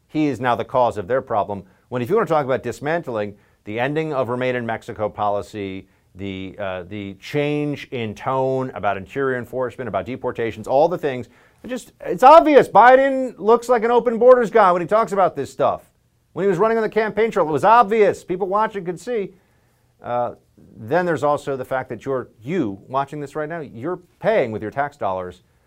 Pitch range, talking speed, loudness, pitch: 110-180 Hz, 205 wpm, -19 LUFS, 130 Hz